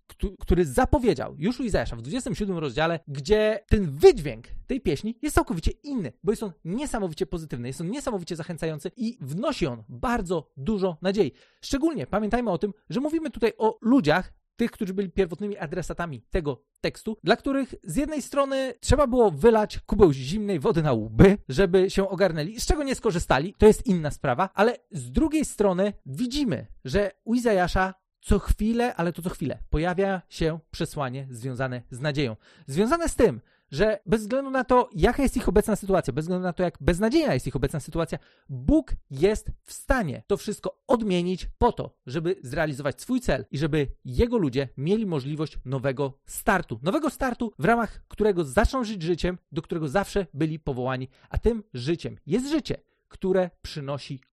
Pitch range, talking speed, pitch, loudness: 155-220 Hz, 170 wpm, 190 Hz, -26 LUFS